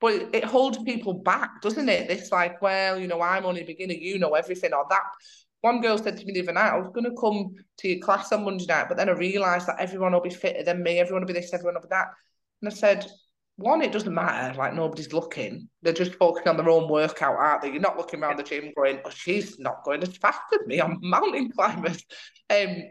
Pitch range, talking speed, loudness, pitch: 170-205 Hz, 255 wpm, -25 LUFS, 185 Hz